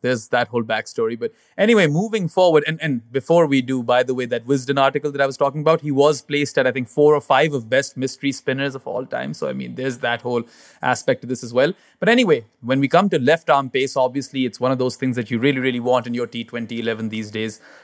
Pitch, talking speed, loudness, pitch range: 130 Hz, 255 wpm, -20 LUFS, 120-145 Hz